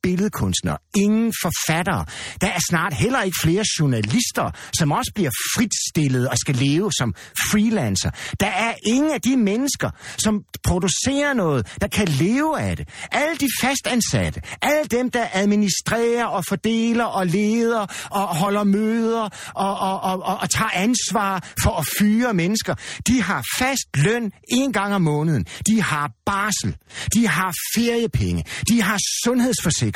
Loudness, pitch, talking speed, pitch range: -20 LUFS, 200 Hz, 150 wpm, 160-230 Hz